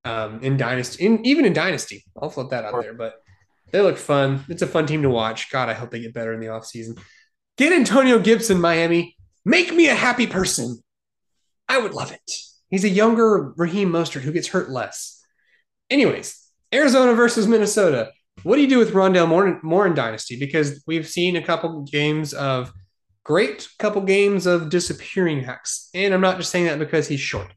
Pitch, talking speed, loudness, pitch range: 165 Hz, 195 wpm, -19 LUFS, 125-195 Hz